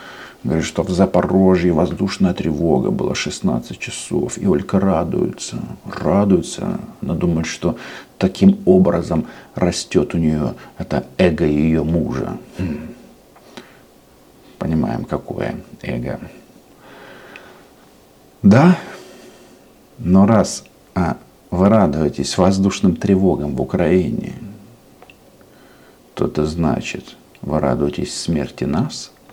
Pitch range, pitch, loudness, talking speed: 75-95 Hz, 85 Hz, -18 LUFS, 90 wpm